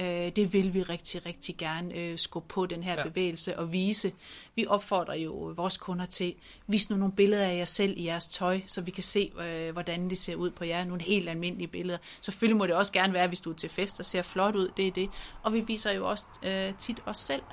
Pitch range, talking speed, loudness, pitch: 175-195 Hz, 235 wpm, -30 LUFS, 185 Hz